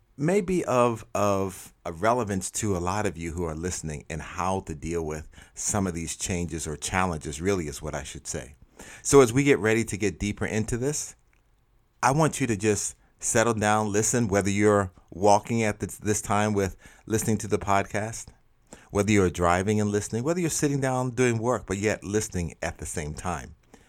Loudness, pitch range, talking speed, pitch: -26 LUFS, 90-110 Hz, 195 wpm, 105 Hz